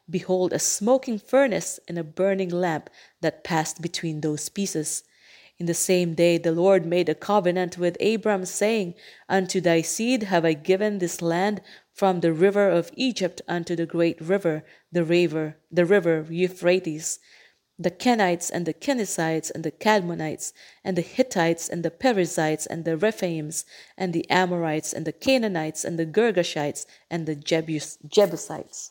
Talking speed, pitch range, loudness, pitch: 160 wpm, 165-195 Hz, -24 LUFS, 175 Hz